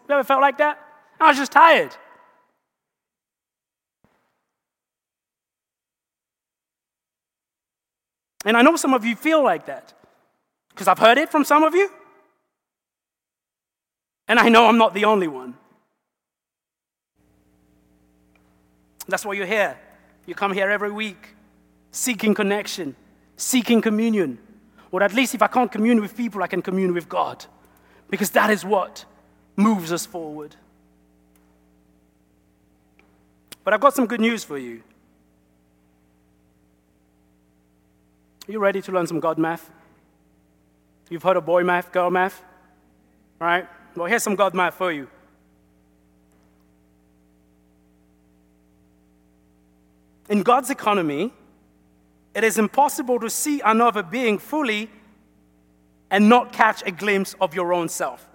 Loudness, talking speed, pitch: -20 LUFS, 125 wpm, 175 Hz